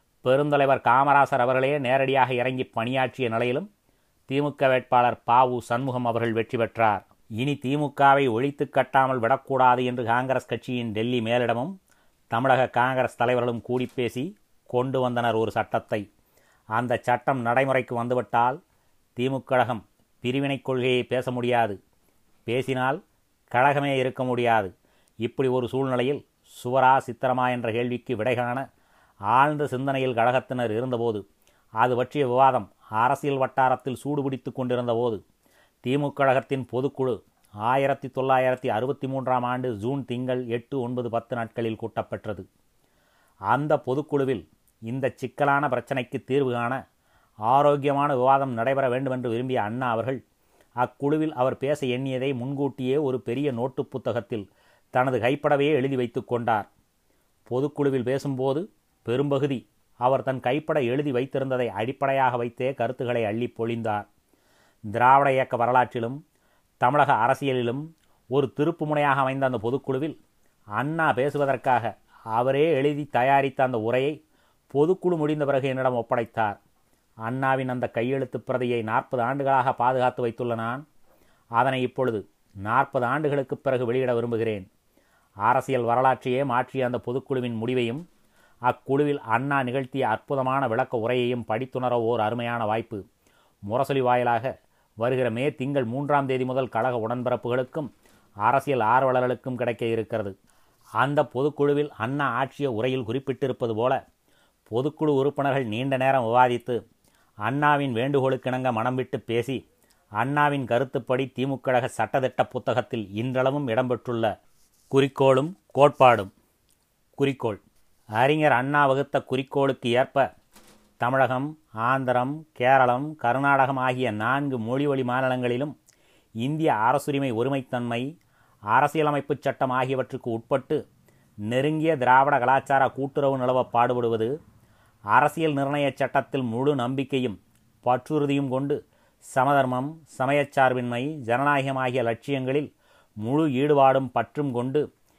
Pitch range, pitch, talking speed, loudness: 120-135 Hz, 130 Hz, 105 wpm, -25 LUFS